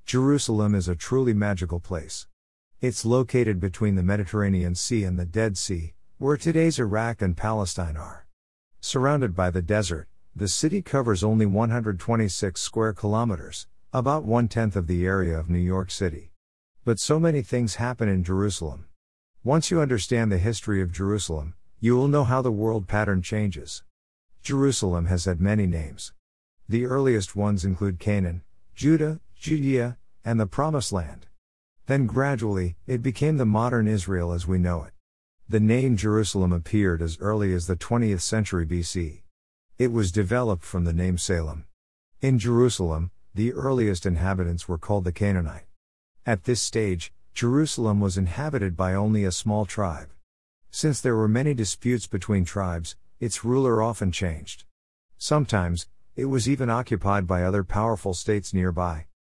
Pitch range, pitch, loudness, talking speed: 90-115 Hz, 100 Hz, -25 LUFS, 155 wpm